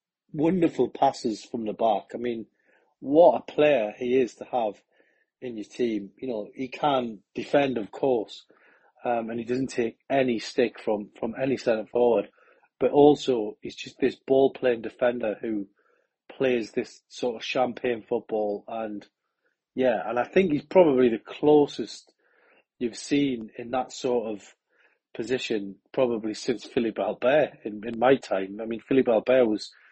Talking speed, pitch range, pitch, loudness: 160 wpm, 110-130 Hz, 120 Hz, -26 LUFS